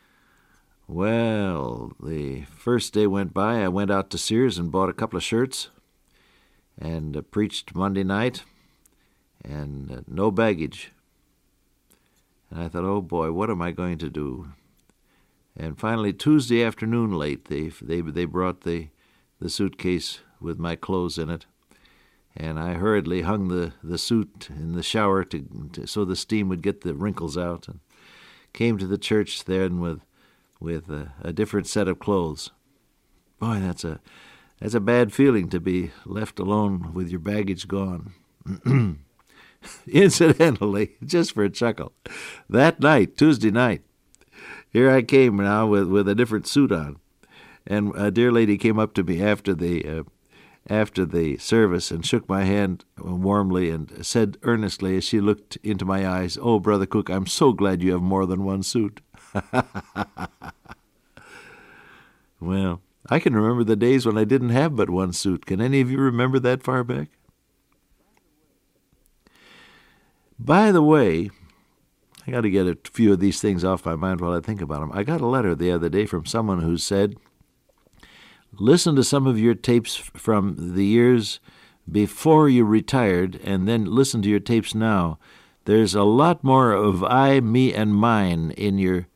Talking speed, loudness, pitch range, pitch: 165 wpm, -22 LUFS, 90-115 Hz, 100 Hz